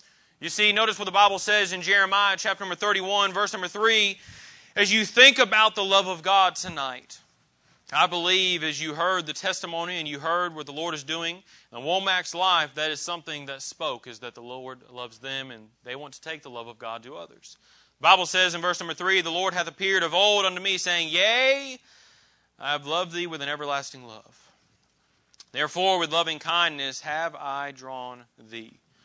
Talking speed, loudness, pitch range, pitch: 200 wpm, -23 LUFS, 145-195 Hz, 175 Hz